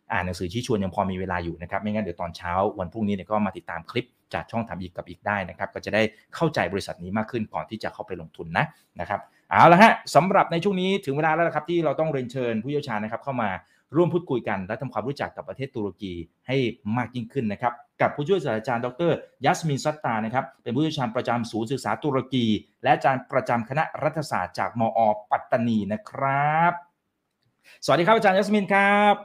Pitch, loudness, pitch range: 120 Hz, -24 LUFS, 105-145 Hz